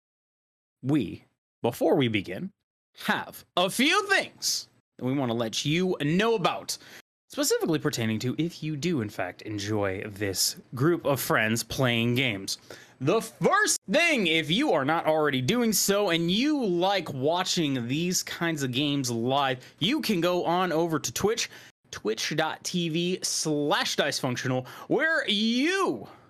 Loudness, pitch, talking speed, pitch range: -26 LUFS, 160 Hz, 140 wpm, 130-190 Hz